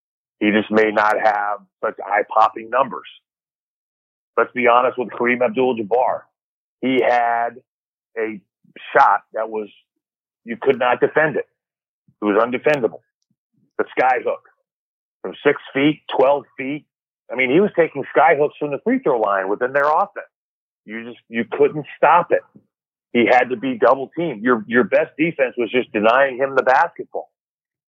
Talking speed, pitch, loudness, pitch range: 150 wpm, 125 Hz, -18 LUFS, 115-150 Hz